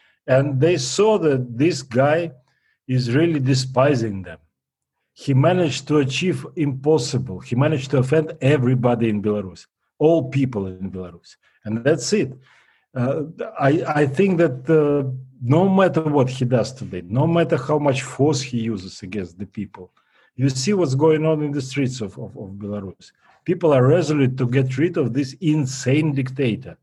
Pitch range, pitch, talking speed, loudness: 120-155 Hz, 135 Hz, 165 wpm, -20 LUFS